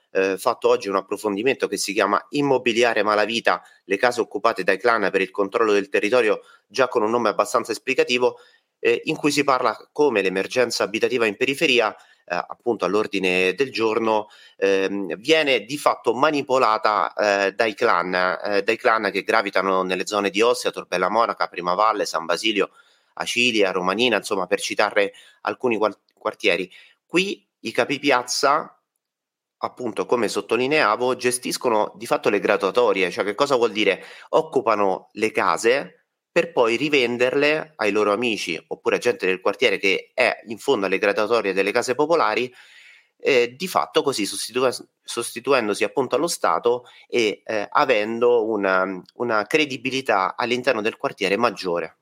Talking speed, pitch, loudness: 150 wpm, 125 Hz, -21 LUFS